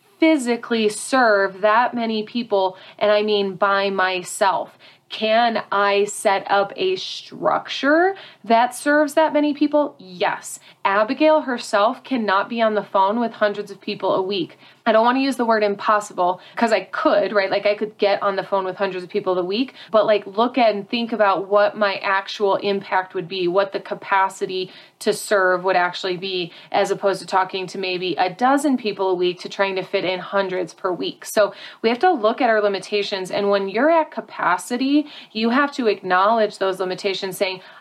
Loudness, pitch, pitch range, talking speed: -20 LUFS, 205 Hz, 195-230 Hz, 190 wpm